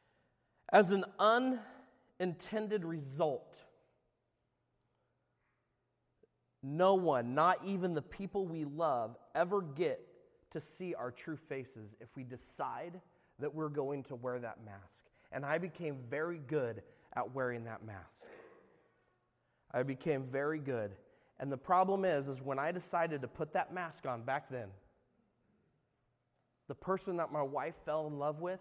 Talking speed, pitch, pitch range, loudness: 140 wpm, 150 Hz, 130-180 Hz, -37 LUFS